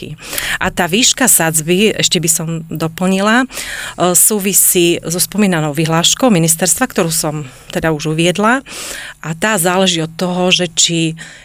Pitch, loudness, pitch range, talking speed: 180 Hz, -12 LUFS, 165-195 Hz, 130 wpm